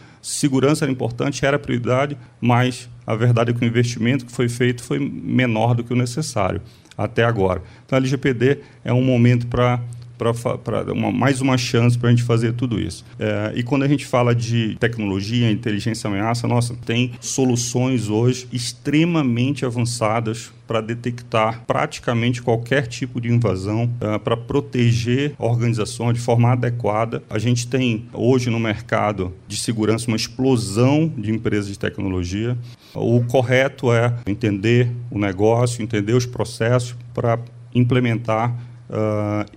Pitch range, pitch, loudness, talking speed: 110-125 Hz, 120 Hz, -20 LUFS, 145 wpm